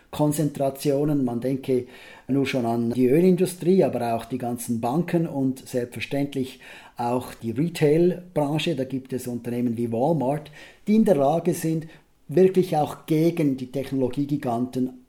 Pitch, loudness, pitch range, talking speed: 135 Hz, -24 LUFS, 125-160 Hz, 135 wpm